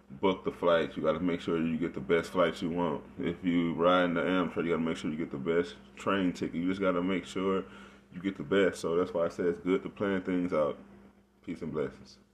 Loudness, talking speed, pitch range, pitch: -31 LUFS, 270 wpm, 85-95 Hz, 90 Hz